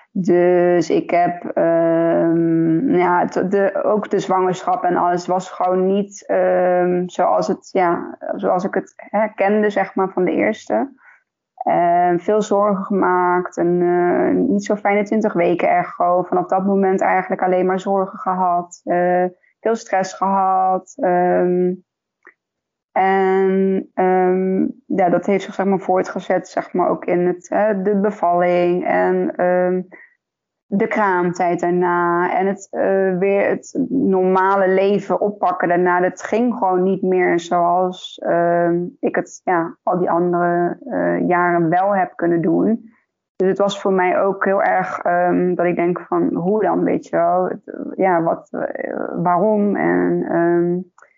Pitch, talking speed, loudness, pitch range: 185 Hz, 150 wpm, -18 LUFS, 175-195 Hz